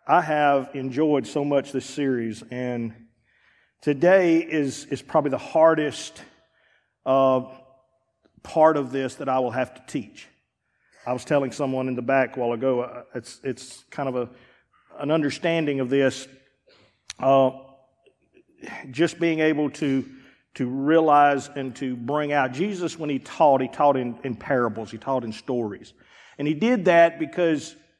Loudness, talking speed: -23 LUFS, 155 wpm